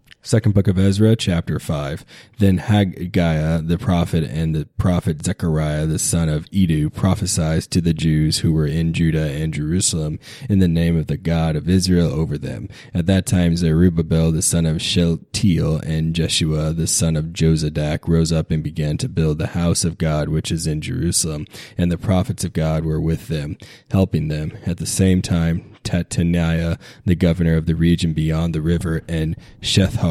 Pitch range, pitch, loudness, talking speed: 80-90 Hz, 85 Hz, -19 LUFS, 180 wpm